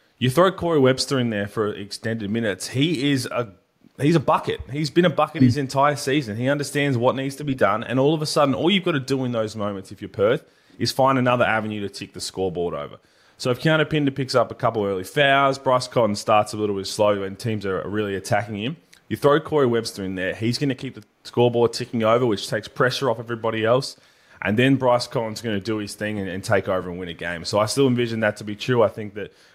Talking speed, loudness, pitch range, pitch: 255 wpm, -22 LUFS, 105-135 Hz, 120 Hz